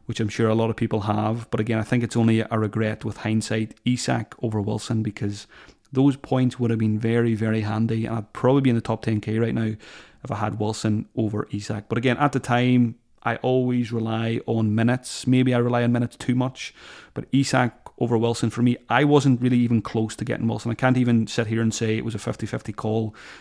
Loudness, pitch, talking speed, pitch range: -23 LUFS, 115 Hz, 230 wpm, 110-125 Hz